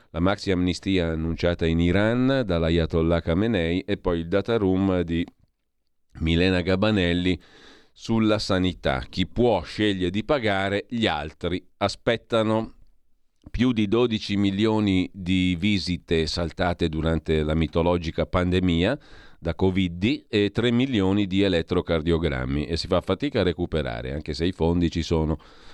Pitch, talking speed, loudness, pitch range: 90 Hz, 135 wpm, -24 LUFS, 85-100 Hz